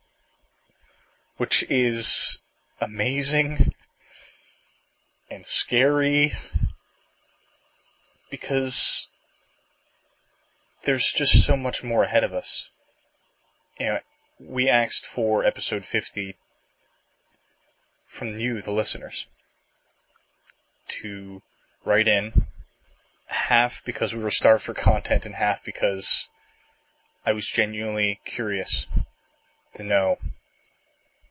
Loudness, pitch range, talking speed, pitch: -23 LUFS, 105-140 Hz, 85 wpm, 115 Hz